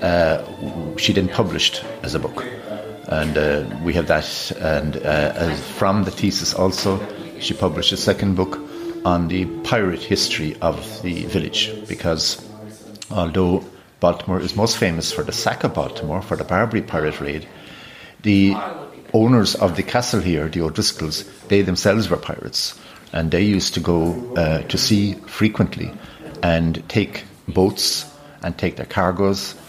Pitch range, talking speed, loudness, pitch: 85-105 Hz, 150 wpm, -20 LUFS, 95 Hz